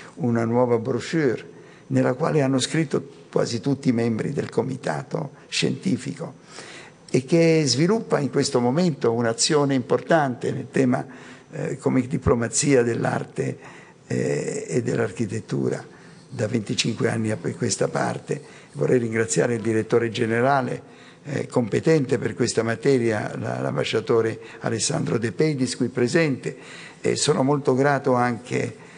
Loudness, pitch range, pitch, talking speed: -23 LUFS, 115-140 Hz, 125 Hz, 120 wpm